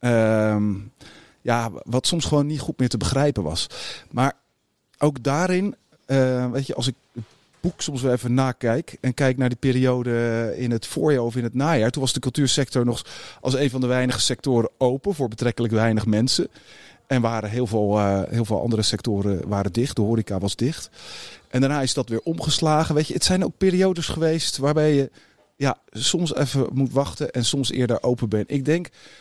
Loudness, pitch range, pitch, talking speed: -22 LUFS, 115-140 Hz, 125 Hz, 195 wpm